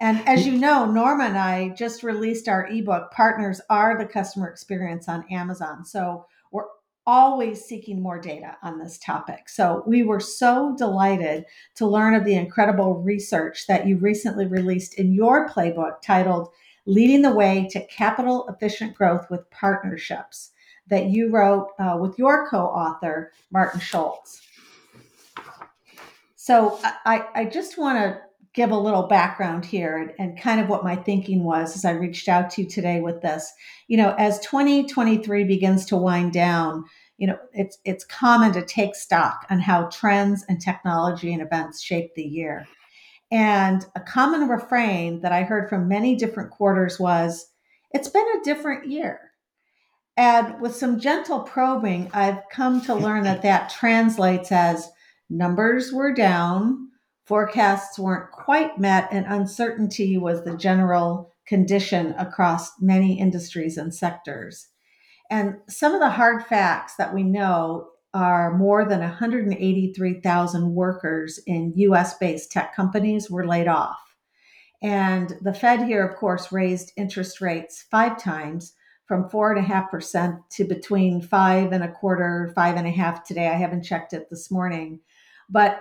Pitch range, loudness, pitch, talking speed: 175-220 Hz, -22 LUFS, 195 Hz, 155 wpm